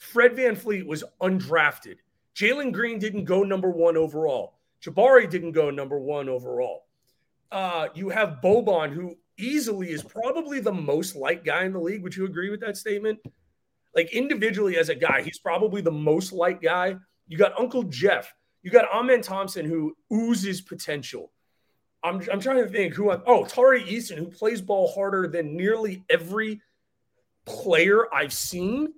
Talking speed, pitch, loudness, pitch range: 170 wpm, 195 Hz, -24 LUFS, 170-225 Hz